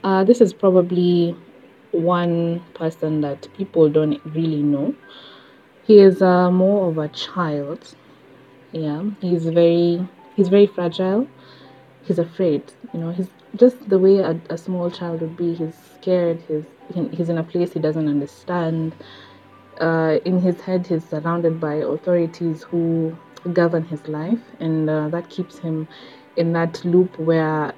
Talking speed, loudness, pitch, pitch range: 150 wpm, -20 LUFS, 170 Hz, 155-180 Hz